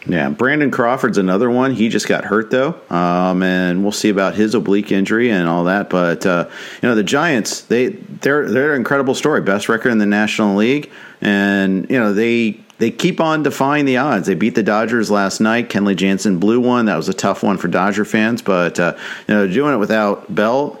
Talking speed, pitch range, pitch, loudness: 215 wpm, 95-115 Hz, 105 Hz, -16 LUFS